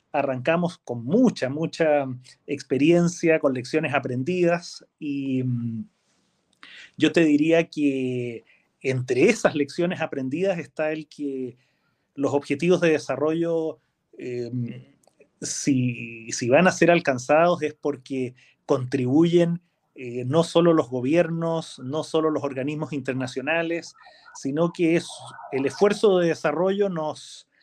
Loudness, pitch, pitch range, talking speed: -23 LUFS, 150 Hz, 130-165 Hz, 115 wpm